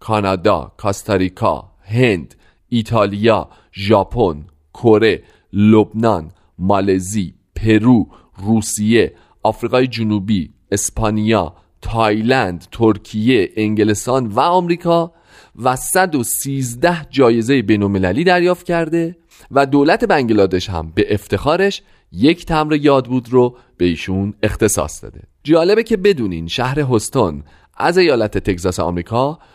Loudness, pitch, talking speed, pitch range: -16 LUFS, 110 Hz, 95 wpm, 100-130 Hz